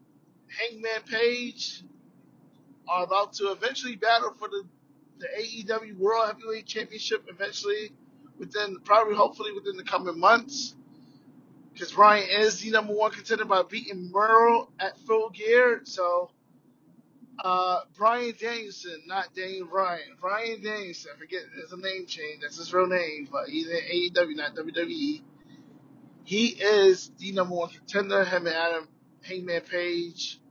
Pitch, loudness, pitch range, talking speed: 200 Hz, -26 LUFS, 180-225 Hz, 140 wpm